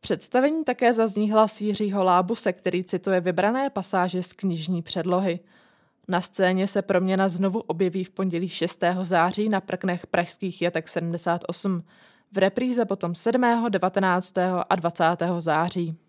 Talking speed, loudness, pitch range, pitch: 130 wpm, -24 LUFS, 175-205 Hz, 185 Hz